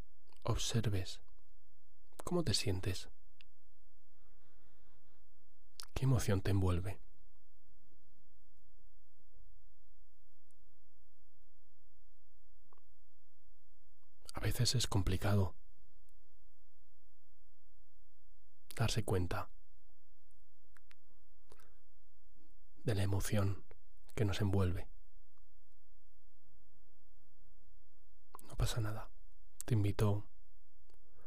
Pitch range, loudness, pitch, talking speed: 80-100 Hz, -38 LUFS, 90 Hz, 50 wpm